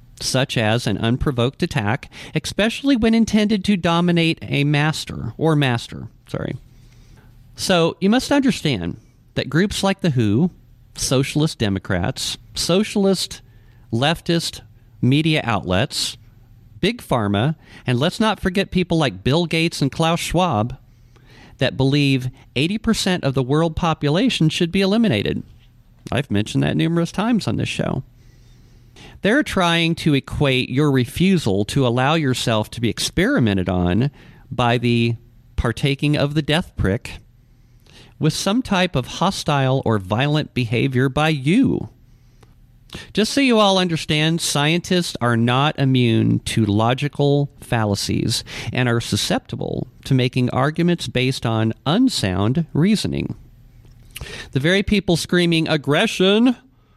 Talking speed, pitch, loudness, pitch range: 125 wpm, 135 Hz, -19 LUFS, 120-170 Hz